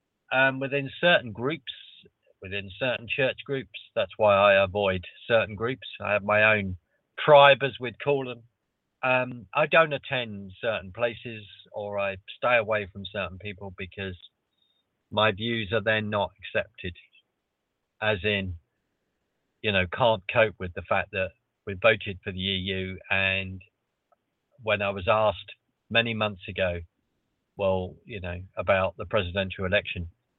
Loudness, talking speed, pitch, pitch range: -26 LUFS, 145 wpm, 105 Hz, 95-115 Hz